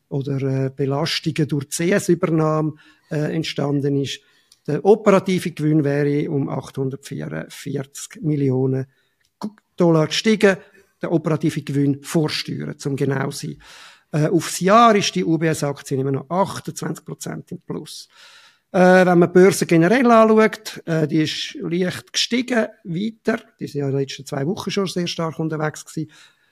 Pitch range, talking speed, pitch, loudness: 140-185 Hz, 140 wpm, 160 Hz, -19 LUFS